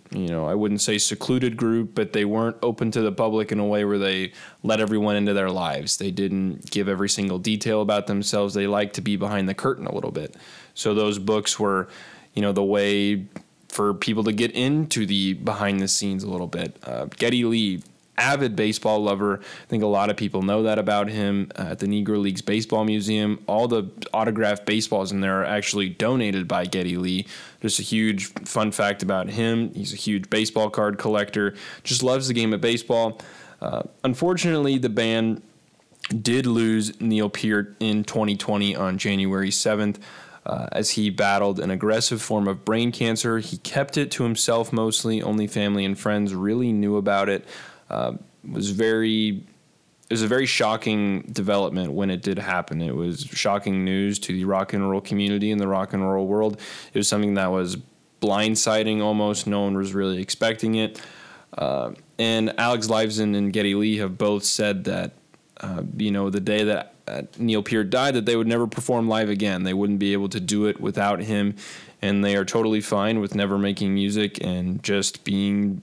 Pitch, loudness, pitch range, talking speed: 105 Hz, -23 LUFS, 100-110 Hz, 195 wpm